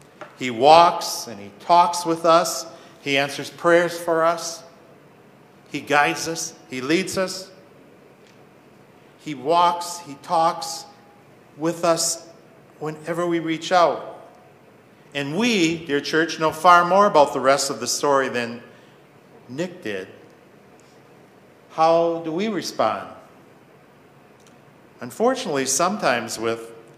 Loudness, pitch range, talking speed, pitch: -20 LUFS, 145-170 Hz, 115 wpm, 165 Hz